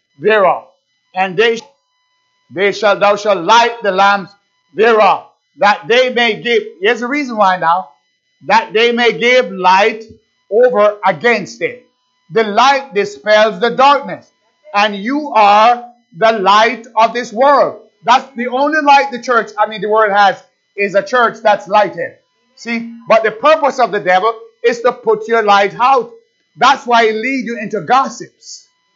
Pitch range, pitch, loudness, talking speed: 205-260 Hz, 230 Hz, -12 LUFS, 160 wpm